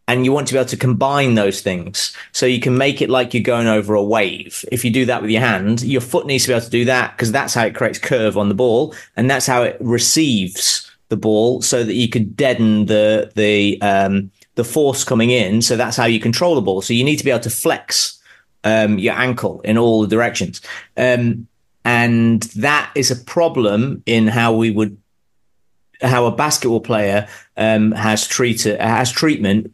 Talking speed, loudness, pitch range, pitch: 215 wpm, -16 LUFS, 110-125 Hz, 115 Hz